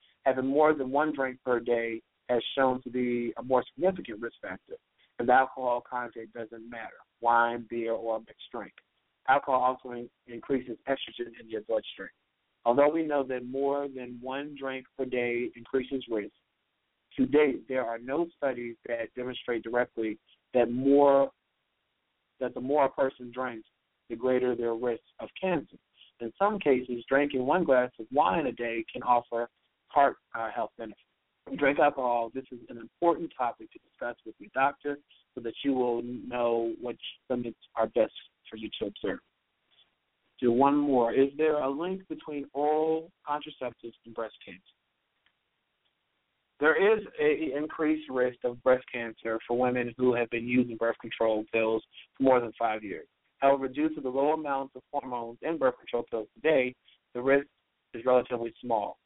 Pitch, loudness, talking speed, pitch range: 125 Hz, -29 LUFS, 165 wpm, 120-140 Hz